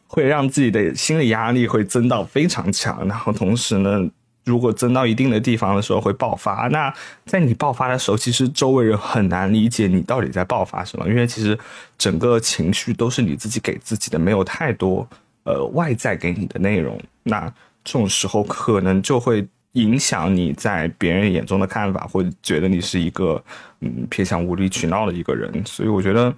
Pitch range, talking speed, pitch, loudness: 95-120 Hz, 300 characters per minute, 110 Hz, -19 LUFS